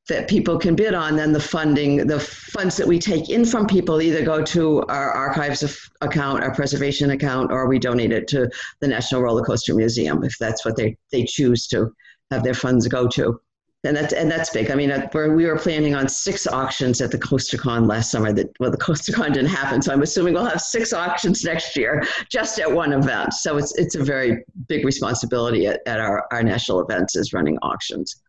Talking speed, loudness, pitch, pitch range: 210 wpm, -20 LUFS, 140 Hz, 125-155 Hz